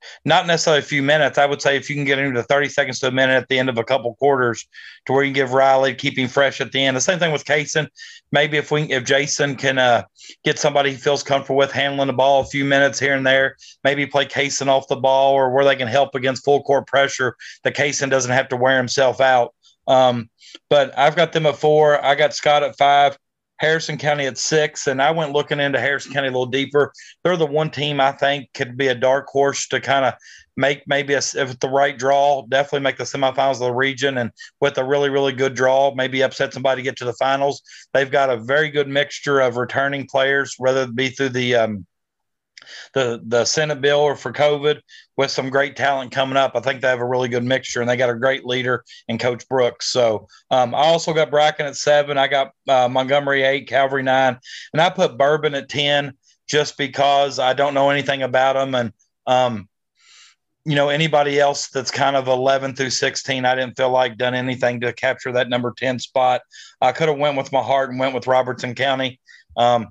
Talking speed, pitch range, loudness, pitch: 230 wpm, 130-140 Hz, -18 LUFS, 135 Hz